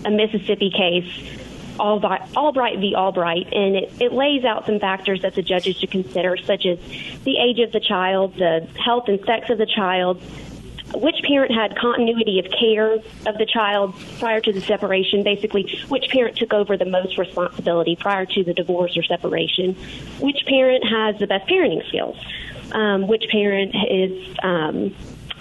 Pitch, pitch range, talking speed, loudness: 205 Hz, 185-225 Hz, 170 wpm, -20 LUFS